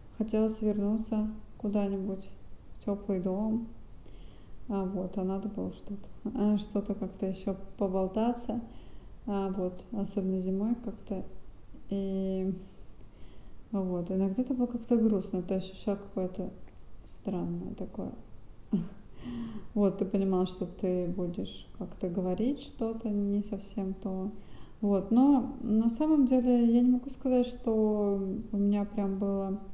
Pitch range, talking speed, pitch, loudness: 195-225 Hz, 120 wpm, 205 Hz, -32 LUFS